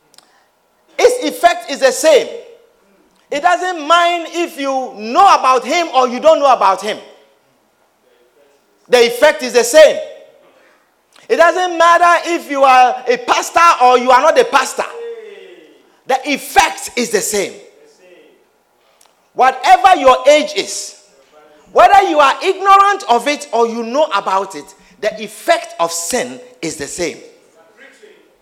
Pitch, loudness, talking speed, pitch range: 310 Hz, -12 LUFS, 135 wpm, 250-385 Hz